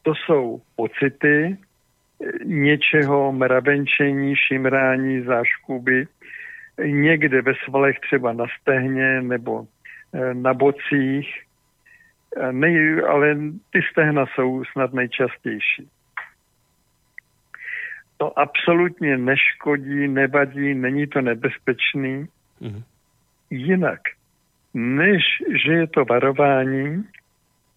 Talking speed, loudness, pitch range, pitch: 90 wpm, -20 LUFS, 130-150 Hz, 140 Hz